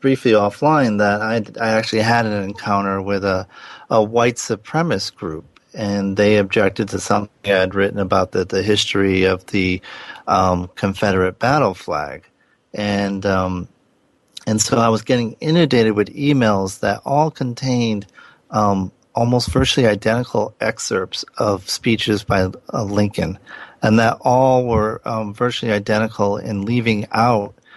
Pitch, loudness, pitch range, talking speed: 105 Hz, -18 LUFS, 100-115 Hz, 145 wpm